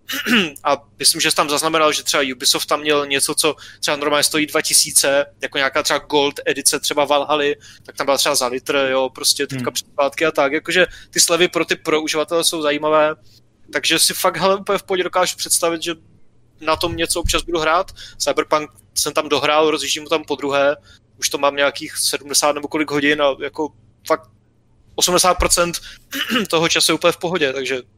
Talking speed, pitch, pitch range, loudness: 190 wpm, 150 Hz, 140-165 Hz, -17 LUFS